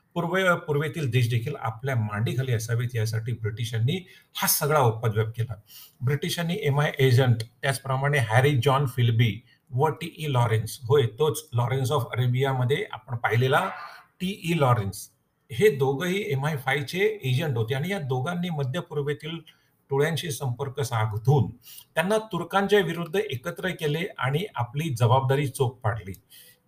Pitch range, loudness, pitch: 120-155 Hz, -26 LUFS, 140 Hz